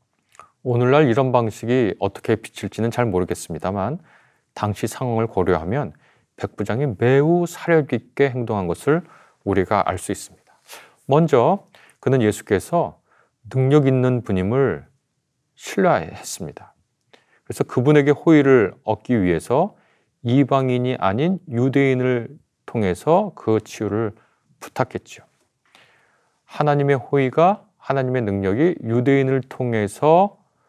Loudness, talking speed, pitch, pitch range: -20 LUFS, 260 characters per minute, 130 Hz, 110-145 Hz